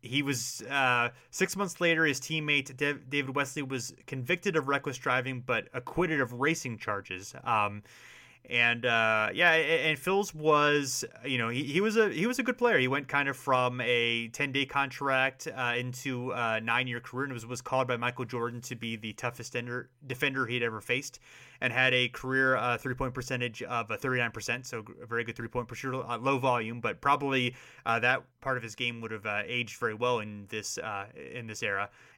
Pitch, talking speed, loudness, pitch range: 125 Hz, 200 wpm, -30 LUFS, 120-140 Hz